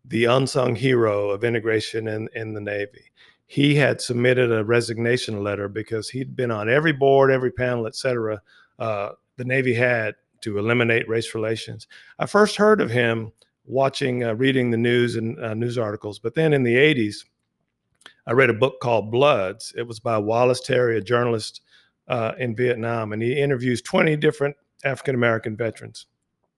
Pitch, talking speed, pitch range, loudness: 120 Hz, 170 wpm, 110-130 Hz, -22 LUFS